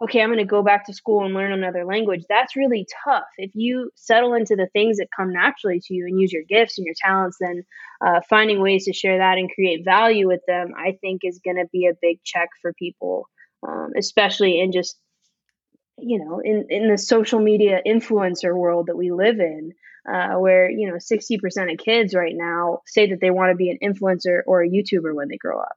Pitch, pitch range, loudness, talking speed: 190 Hz, 180-215 Hz, -20 LUFS, 225 wpm